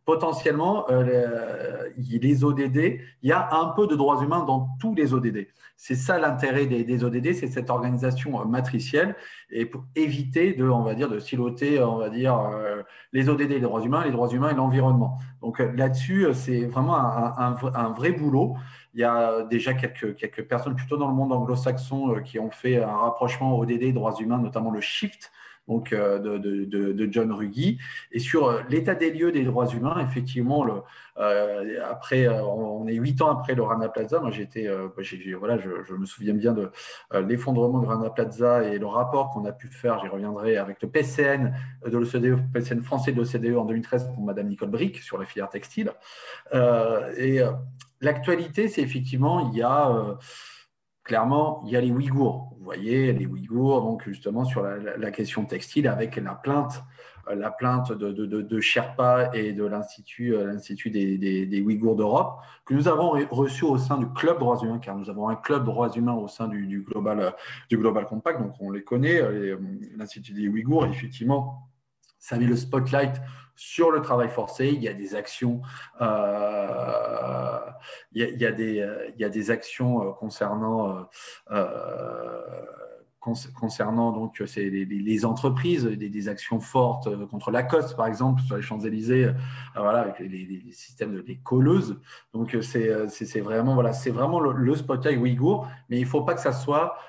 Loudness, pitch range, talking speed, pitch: -25 LUFS, 110-135 Hz, 190 wpm, 125 Hz